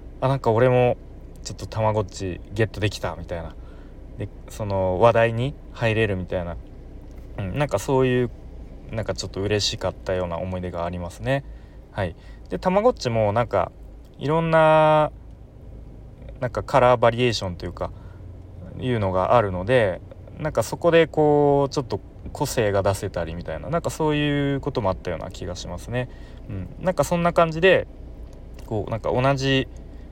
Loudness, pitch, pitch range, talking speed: -23 LUFS, 110 Hz, 95-135 Hz, 350 characters per minute